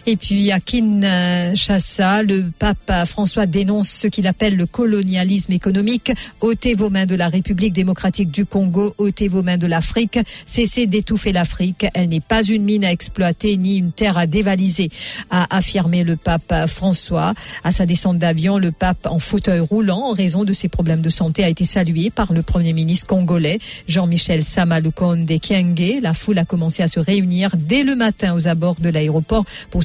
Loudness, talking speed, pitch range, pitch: -16 LUFS, 180 wpm, 175-205 Hz, 190 Hz